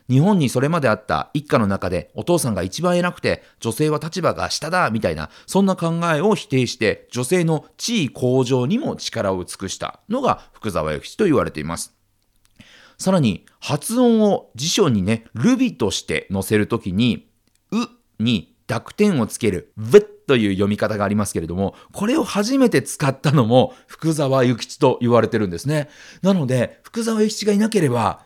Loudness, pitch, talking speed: -20 LUFS, 135 Hz, 340 characters per minute